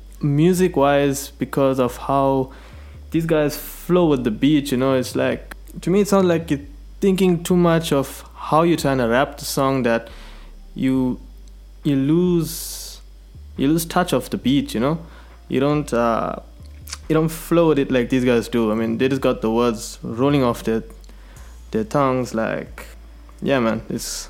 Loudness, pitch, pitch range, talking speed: -20 LUFS, 135 Hz, 115-155 Hz, 180 wpm